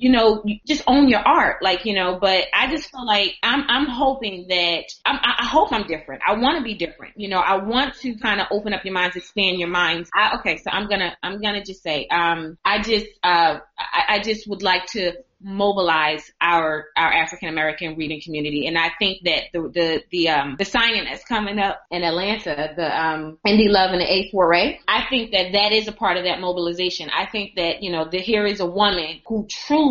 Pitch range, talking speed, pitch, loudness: 170-215 Hz, 230 wpm, 190 Hz, -20 LUFS